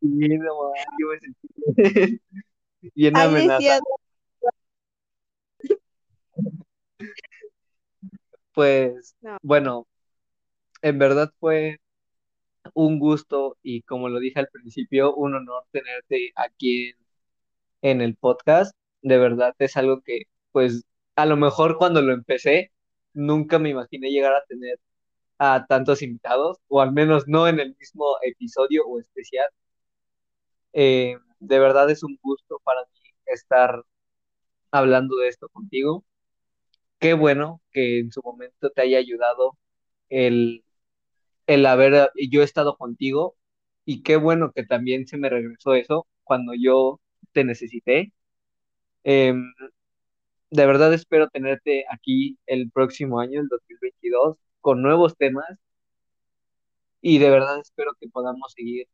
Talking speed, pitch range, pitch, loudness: 120 wpm, 125-155 Hz, 140 Hz, -21 LUFS